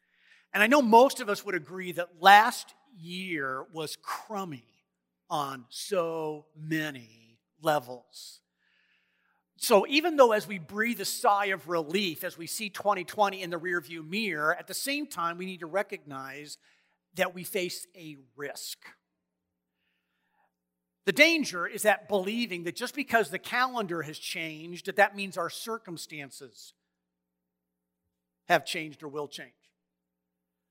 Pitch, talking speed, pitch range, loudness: 170 Hz, 135 wpm, 130-200 Hz, -28 LUFS